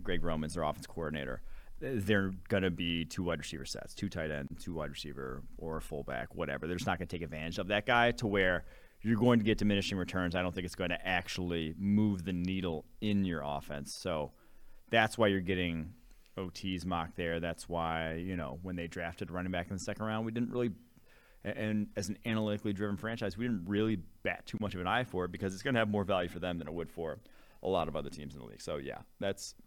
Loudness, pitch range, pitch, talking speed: -35 LUFS, 85-105 Hz, 90 Hz, 240 wpm